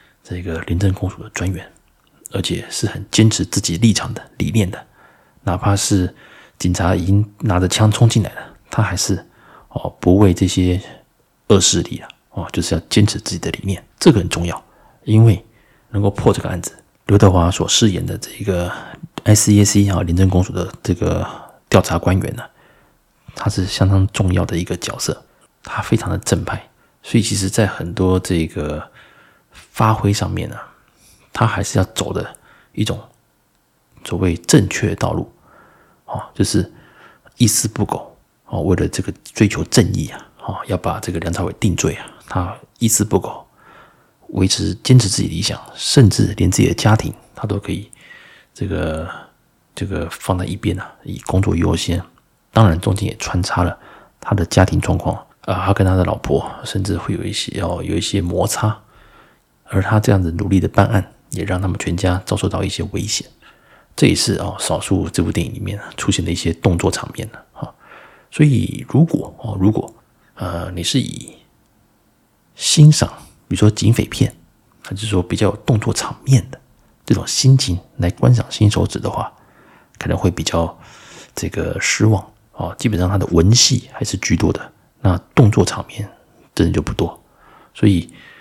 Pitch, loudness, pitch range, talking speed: 100 Hz, -17 LUFS, 90-110 Hz, 250 characters per minute